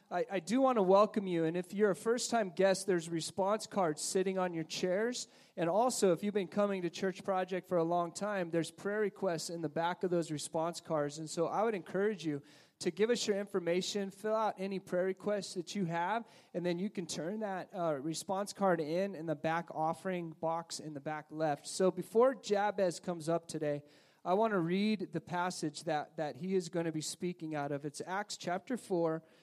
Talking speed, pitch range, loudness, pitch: 220 wpm, 165-200 Hz, -35 LUFS, 180 Hz